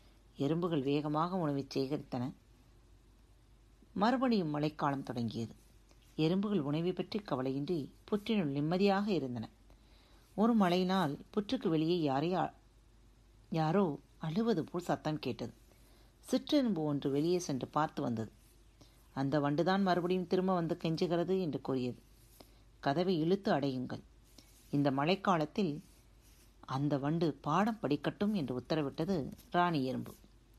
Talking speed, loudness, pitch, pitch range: 100 wpm, -34 LUFS, 150 Hz, 125-180 Hz